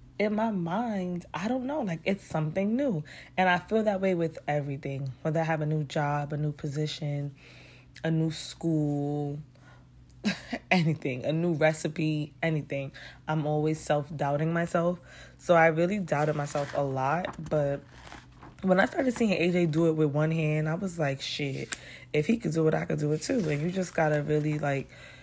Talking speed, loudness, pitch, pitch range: 185 wpm, -29 LUFS, 155 Hz, 145-175 Hz